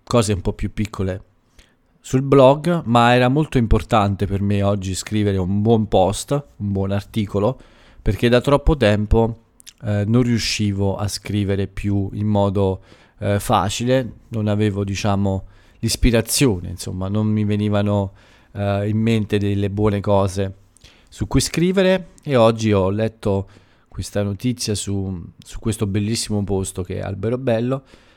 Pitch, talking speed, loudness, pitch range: 105 Hz, 145 wpm, -20 LUFS, 100-115 Hz